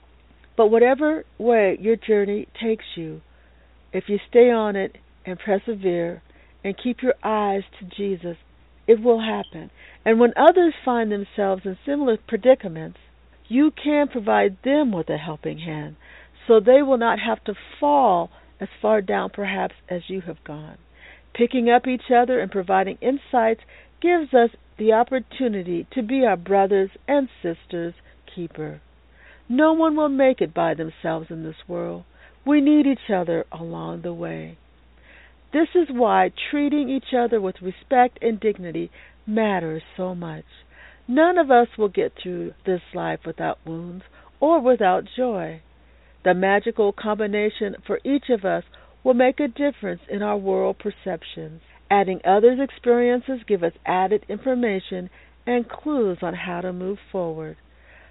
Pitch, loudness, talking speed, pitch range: 205 Hz, -21 LUFS, 150 wpm, 175-245 Hz